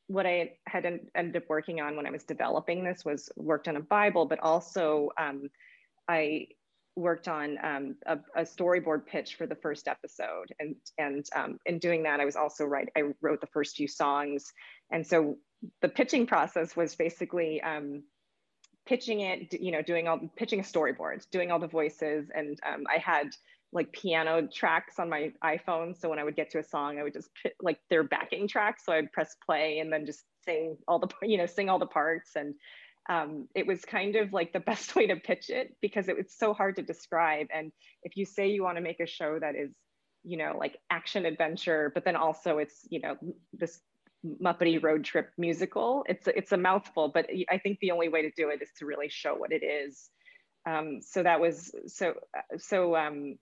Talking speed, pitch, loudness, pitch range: 210 wpm, 165 Hz, -31 LUFS, 155-185 Hz